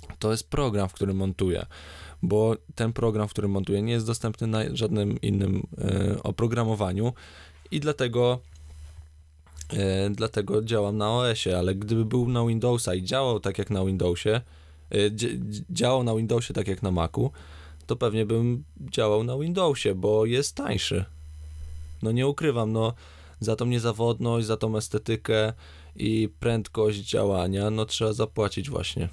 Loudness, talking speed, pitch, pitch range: -26 LUFS, 140 wpm, 105 Hz, 95-115 Hz